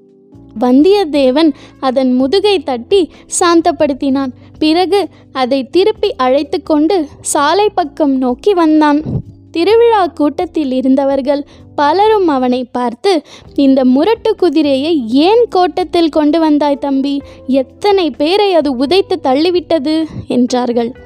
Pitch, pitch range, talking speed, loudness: 305 Hz, 270-360 Hz, 95 wpm, -12 LUFS